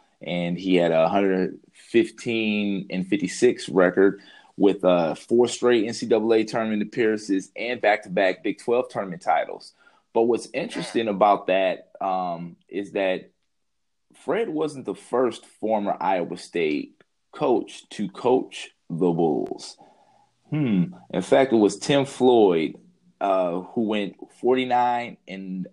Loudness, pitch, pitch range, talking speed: -23 LUFS, 110 Hz, 95-130 Hz, 125 wpm